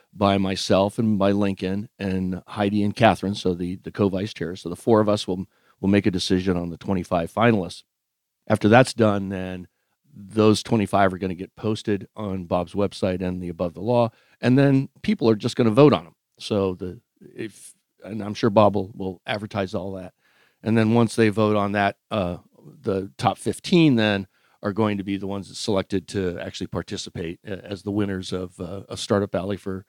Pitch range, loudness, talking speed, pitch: 95-110 Hz, -23 LUFS, 205 wpm, 100 Hz